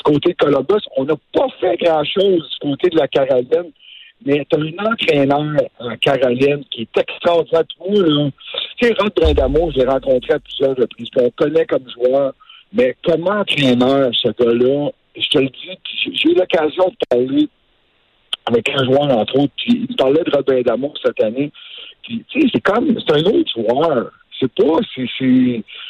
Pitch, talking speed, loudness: 175 Hz, 175 wpm, -16 LUFS